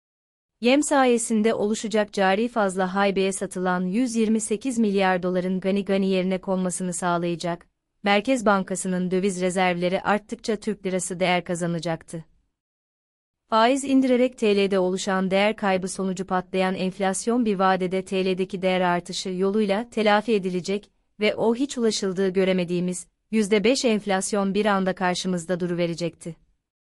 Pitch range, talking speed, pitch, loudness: 185-215 Hz, 120 wpm, 190 Hz, -23 LUFS